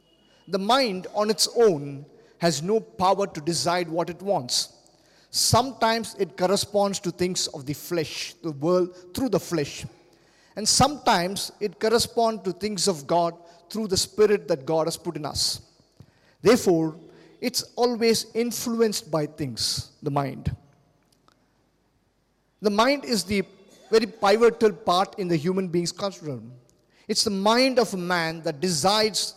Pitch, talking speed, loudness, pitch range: 190 Hz, 145 wpm, -24 LUFS, 170-220 Hz